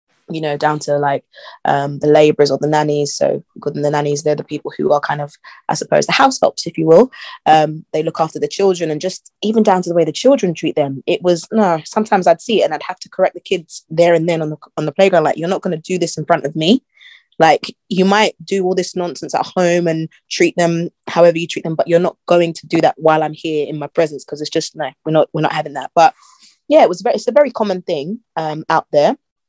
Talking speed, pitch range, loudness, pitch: 270 wpm, 150-185 Hz, -16 LUFS, 165 Hz